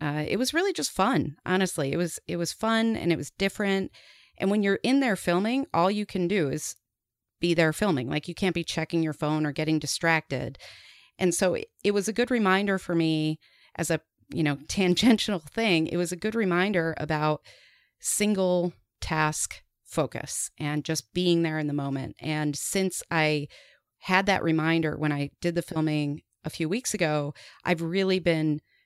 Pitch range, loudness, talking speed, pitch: 155-190 Hz, -27 LUFS, 185 wpm, 170 Hz